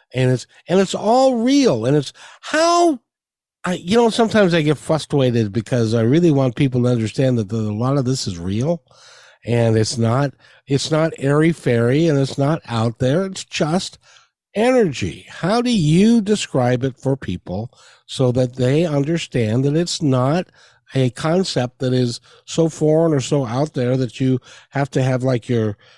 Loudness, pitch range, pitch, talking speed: -18 LUFS, 125-170 Hz, 140 Hz, 175 wpm